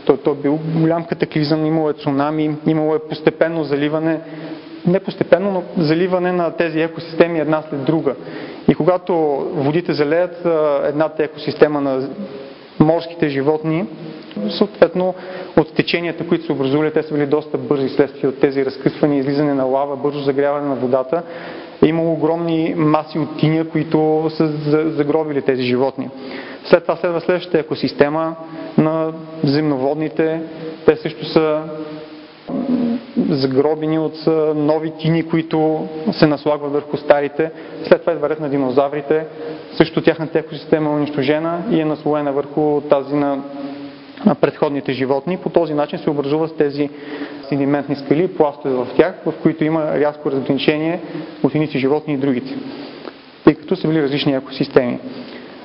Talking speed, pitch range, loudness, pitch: 140 wpm, 145-160 Hz, -18 LUFS, 155 Hz